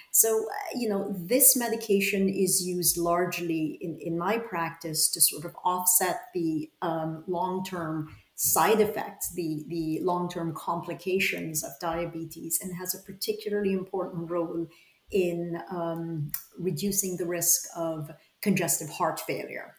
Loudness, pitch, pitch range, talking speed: -27 LUFS, 175 Hz, 165-195 Hz, 135 wpm